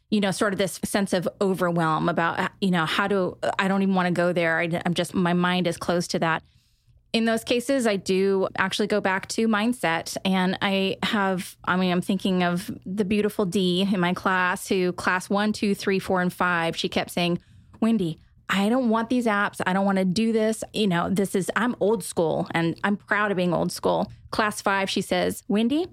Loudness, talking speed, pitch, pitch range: -24 LUFS, 220 wpm, 195 Hz, 180-210 Hz